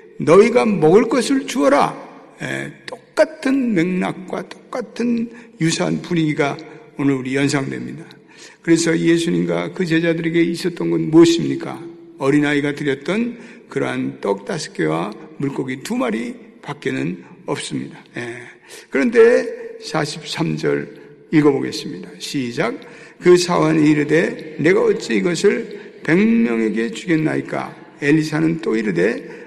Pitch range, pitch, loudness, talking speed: 145-230 Hz, 165 Hz, -18 LUFS, 270 characters per minute